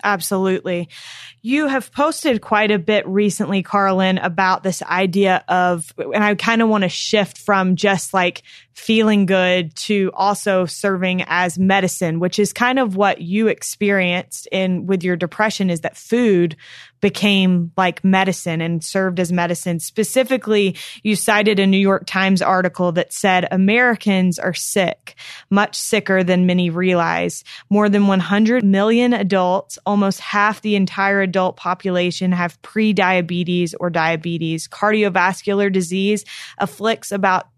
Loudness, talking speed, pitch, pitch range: -17 LUFS, 140 wpm, 190 Hz, 180-205 Hz